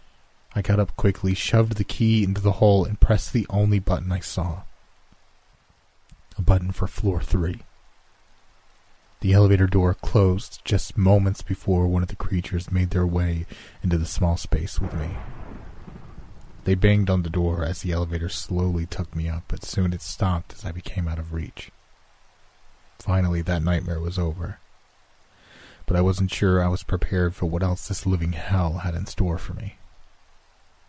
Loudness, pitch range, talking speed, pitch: -24 LUFS, 85-100 Hz, 170 wpm, 90 Hz